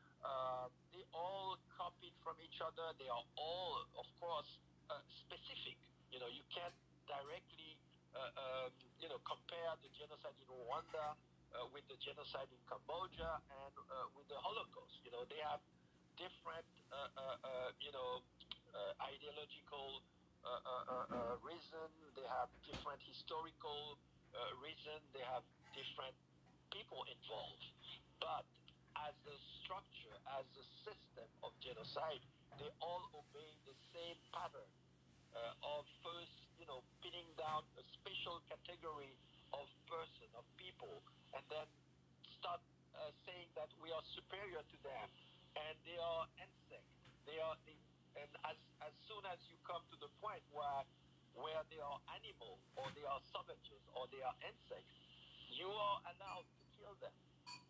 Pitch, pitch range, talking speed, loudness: 150 Hz, 135-165 Hz, 150 wpm, -51 LUFS